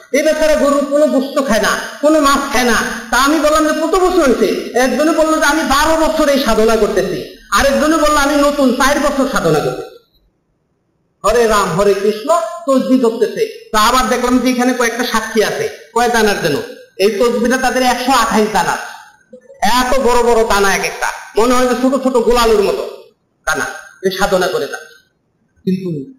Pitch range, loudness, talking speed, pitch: 230-310 Hz, -13 LUFS, 175 wpm, 265 Hz